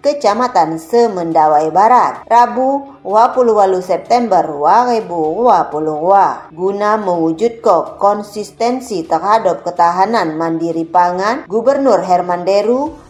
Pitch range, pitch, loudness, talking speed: 170-235 Hz, 200 Hz, -13 LUFS, 80 wpm